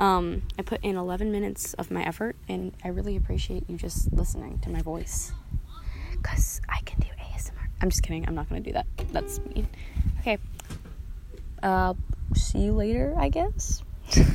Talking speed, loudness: 175 wpm, -30 LUFS